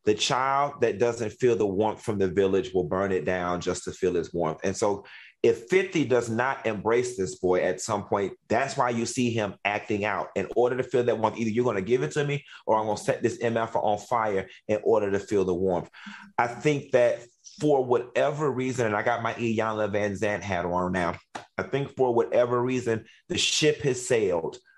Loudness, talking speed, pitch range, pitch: -26 LUFS, 225 wpm, 105-125 Hz, 115 Hz